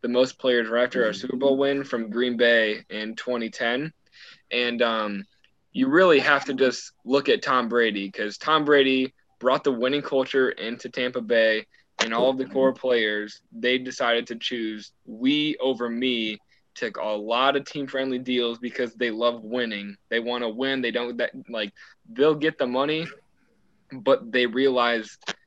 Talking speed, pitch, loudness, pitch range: 175 wpm, 125 Hz, -24 LUFS, 115-135 Hz